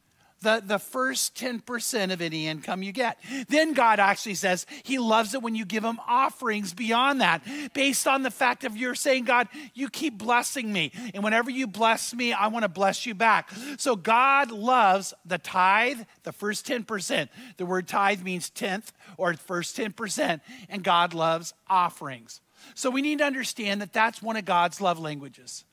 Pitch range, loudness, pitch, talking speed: 190-255 Hz, -25 LUFS, 225 Hz, 180 wpm